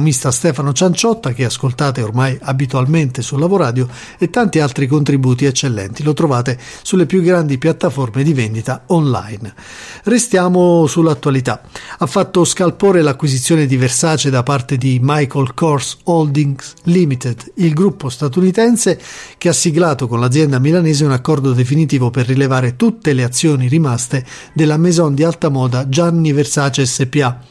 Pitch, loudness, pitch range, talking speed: 145 Hz, -14 LUFS, 130-170 Hz, 140 wpm